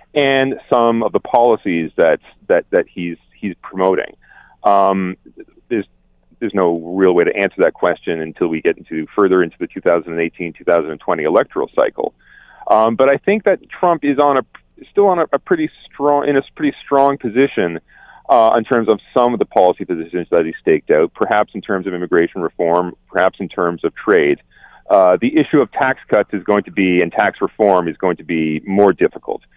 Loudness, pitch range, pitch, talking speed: -16 LUFS, 90-140 Hz, 105 Hz, 195 wpm